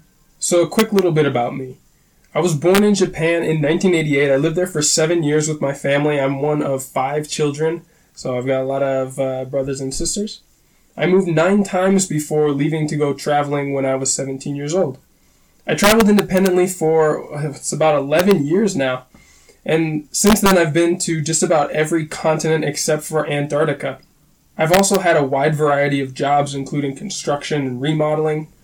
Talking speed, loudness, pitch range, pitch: 180 wpm, -17 LUFS, 140-170 Hz, 155 Hz